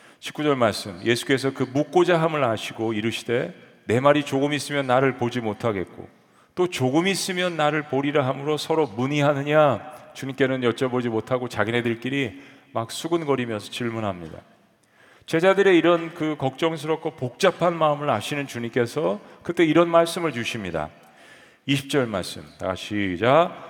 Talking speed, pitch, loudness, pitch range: 325 characters per minute, 135 Hz, -23 LUFS, 120-155 Hz